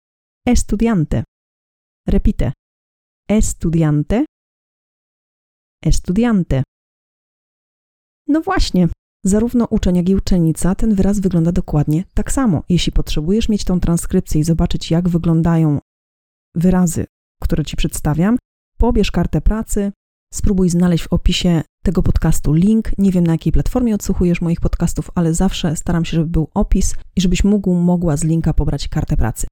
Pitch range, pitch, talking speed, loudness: 160-195 Hz, 175 Hz, 130 wpm, -17 LUFS